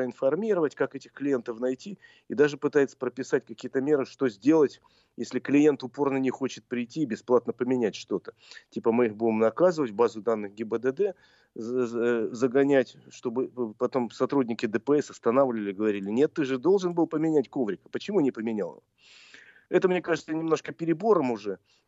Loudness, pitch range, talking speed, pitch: -27 LUFS, 120-145 Hz, 150 wpm, 130 Hz